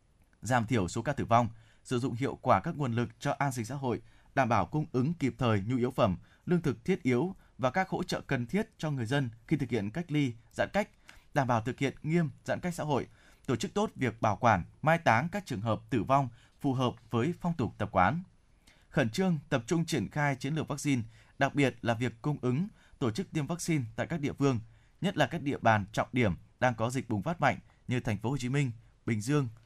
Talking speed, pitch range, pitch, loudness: 245 wpm, 115-150 Hz, 130 Hz, -31 LUFS